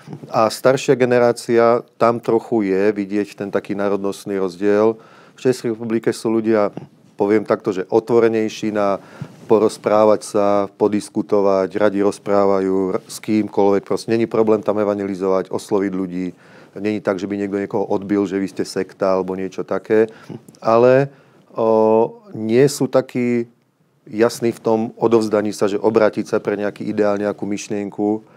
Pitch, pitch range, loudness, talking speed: 105 Hz, 100-115 Hz, -18 LUFS, 140 wpm